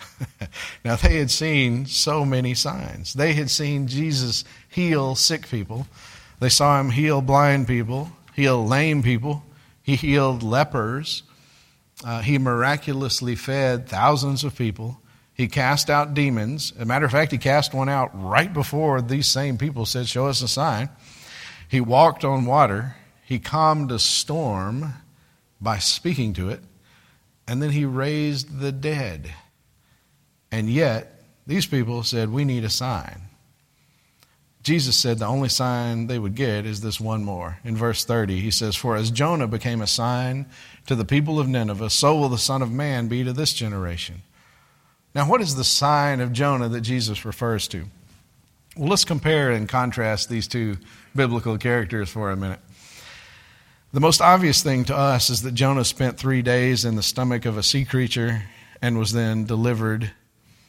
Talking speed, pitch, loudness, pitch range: 165 wpm, 125 Hz, -21 LUFS, 115-140 Hz